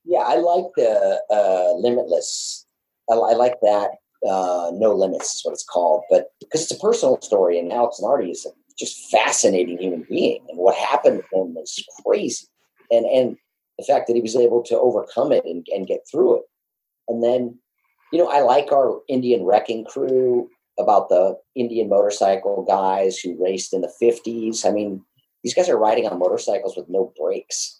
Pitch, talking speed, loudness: 120 Hz, 185 wpm, -20 LUFS